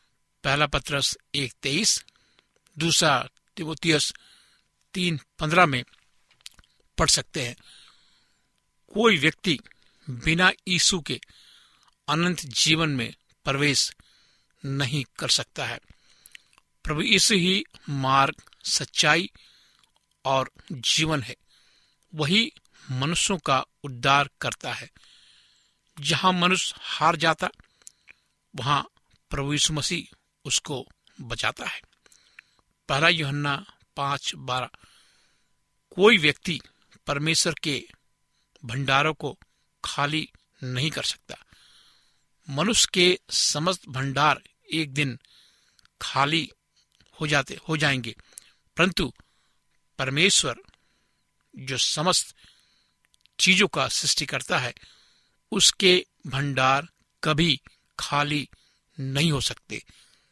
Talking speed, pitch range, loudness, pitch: 90 wpm, 135-170 Hz, -23 LUFS, 150 Hz